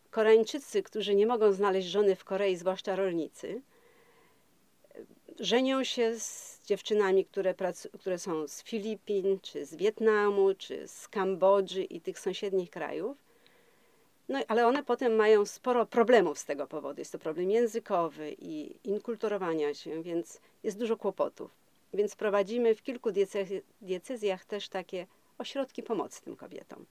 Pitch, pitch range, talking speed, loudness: 210 Hz, 190-235 Hz, 140 wpm, -31 LUFS